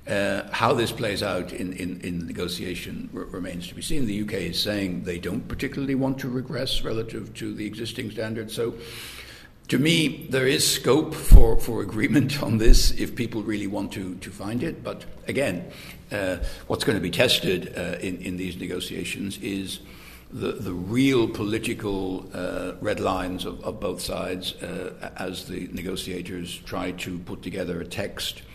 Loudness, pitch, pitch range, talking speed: -26 LUFS, 100 Hz, 90-115 Hz, 175 wpm